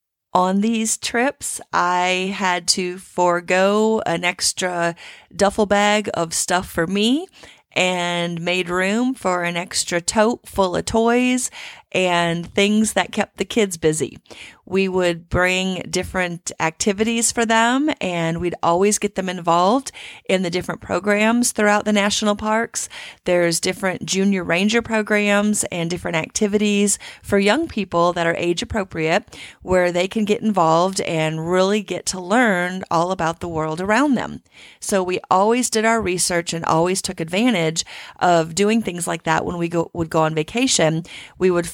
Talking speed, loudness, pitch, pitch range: 155 wpm, -19 LUFS, 185 Hz, 175-210 Hz